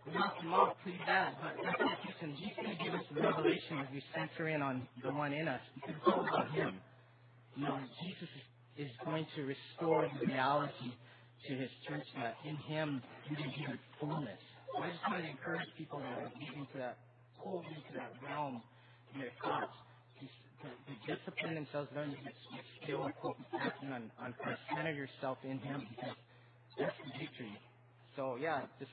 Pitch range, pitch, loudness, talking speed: 125-155 Hz, 140 Hz, -40 LUFS, 180 wpm